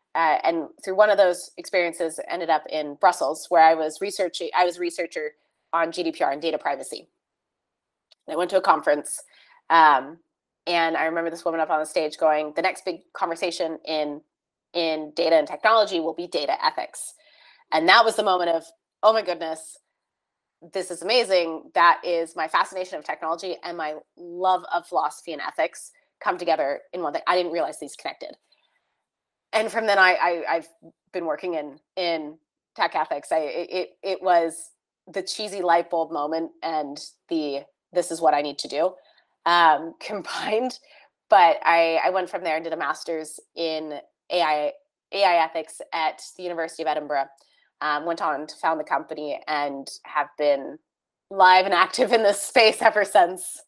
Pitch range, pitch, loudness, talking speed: 160-190 Hz, 170 Hz, -23 LUFS, 175 wpm